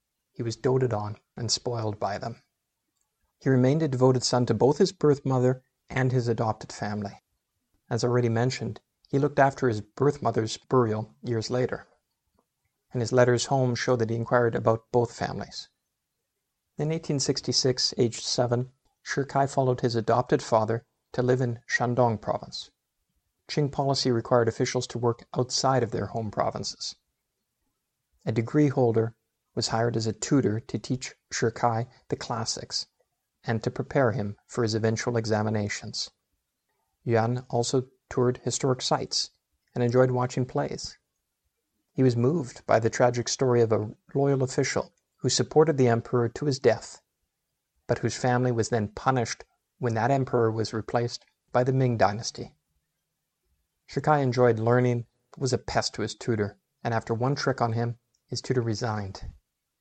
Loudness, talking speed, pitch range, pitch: -27 LUFS, 150 wpm, 115-130 Hz, 125 Hz